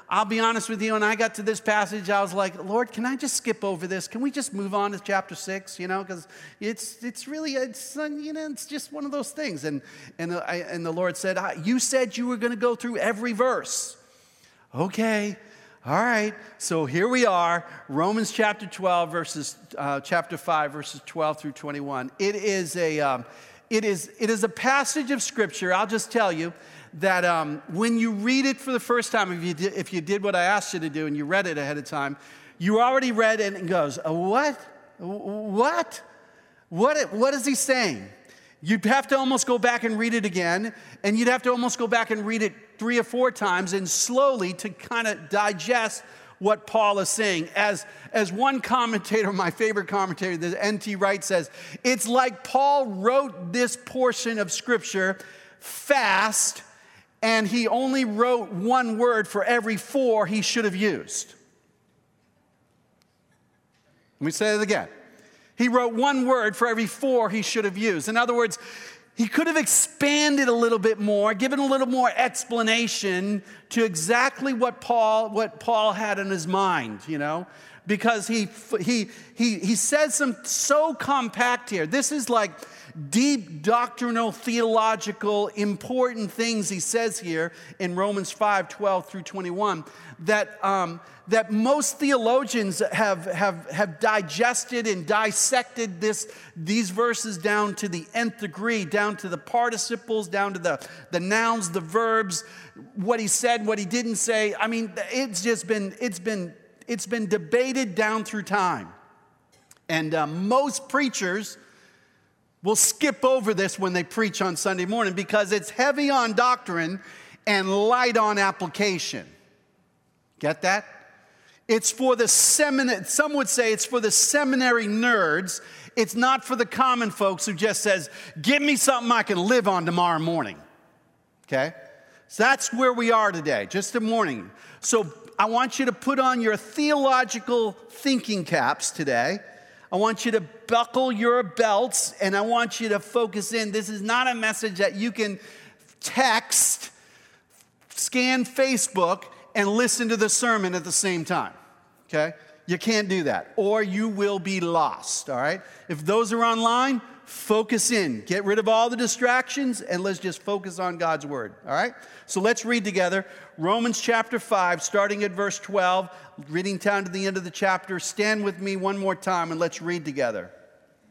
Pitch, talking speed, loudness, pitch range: 215 Hz, 175 wpm, -24 LUFS, 190-240 Hz